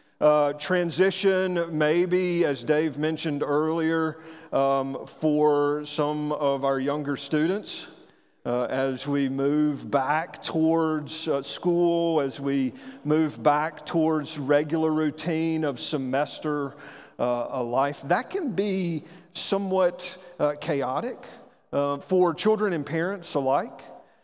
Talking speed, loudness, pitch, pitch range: 110 wpm, -25 LUFS, 155 Hz, 145-170 Hz